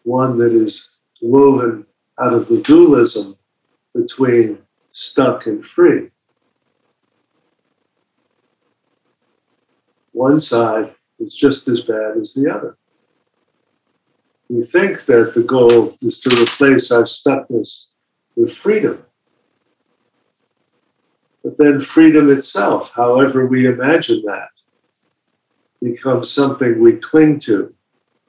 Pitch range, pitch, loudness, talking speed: 120-190 Hz, 140 Hz, -14 LUFS, 100 wpm